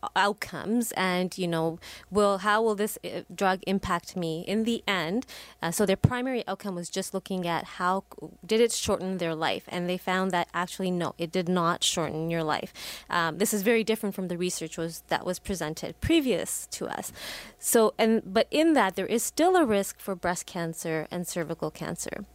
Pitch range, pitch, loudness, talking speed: 170-210 Hz, 185 Hz, -28 LUFS, 195 wpm